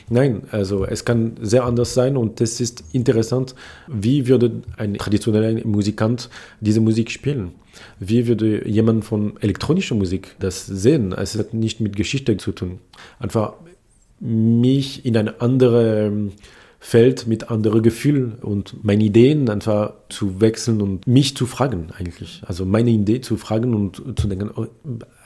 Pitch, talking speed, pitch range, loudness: 110 Hz, 150 wpm, 105-120 Hz, -19 LUFS